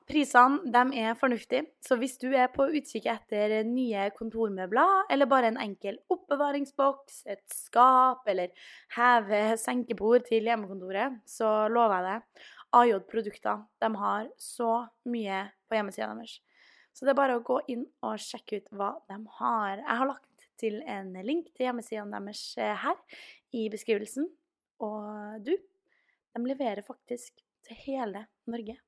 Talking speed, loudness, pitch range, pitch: 145 wpm, -29 LUFS, 215-265 Hz, 235 Hz